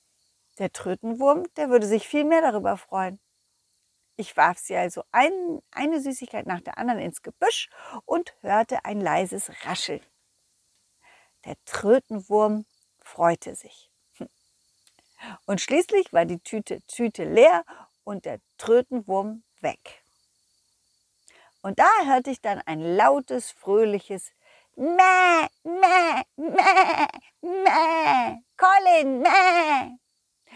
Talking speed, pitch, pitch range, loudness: 110 wpm, 260 Hz, 210-345 Hz, -22 LUFS